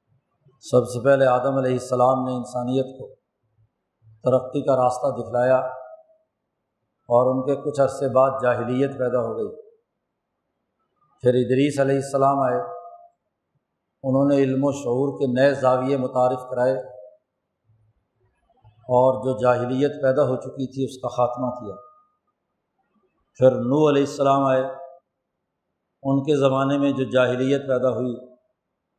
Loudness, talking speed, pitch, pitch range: -21 LUFS, 130 wpm, 130 Hz, 125-140 Hz